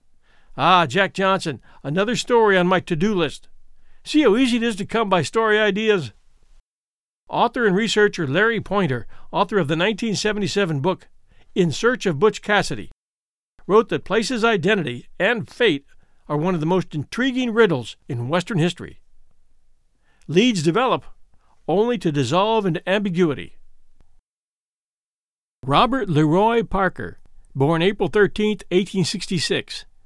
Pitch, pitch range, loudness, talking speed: 190 Hz, 165-215 Hz, -20 LUFS, 130 wpm